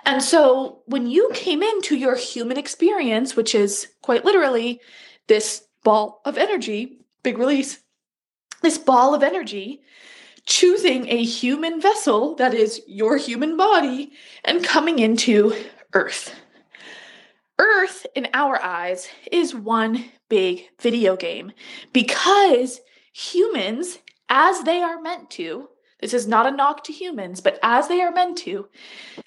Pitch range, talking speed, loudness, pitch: 235-345 Hz, 135 wpm, -20 LUFS, 270 Hz